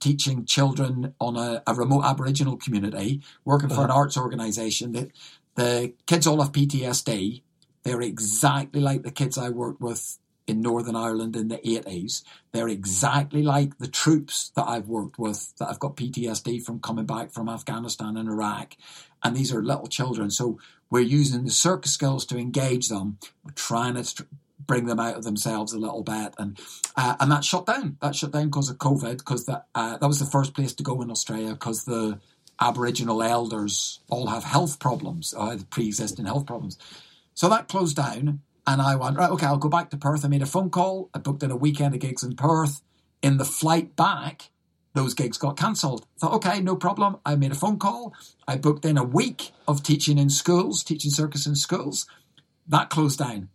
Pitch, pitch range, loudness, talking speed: 140 Hz, 115-145 Hz, -25 LUFS, 195 wpm